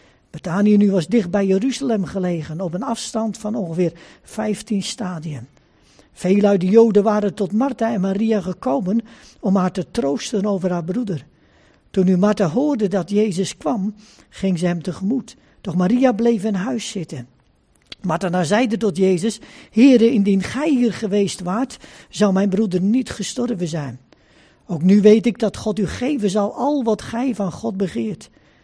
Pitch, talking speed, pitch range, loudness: 205 Hz, 165 wpm, 185-225 Hz, -19 LUFS